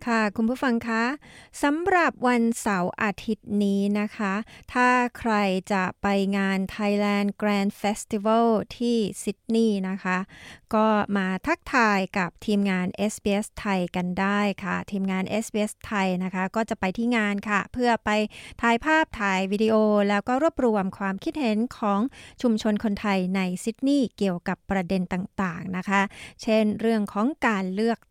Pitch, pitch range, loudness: 210 Hz, 195-230 Hz, -25 LUFS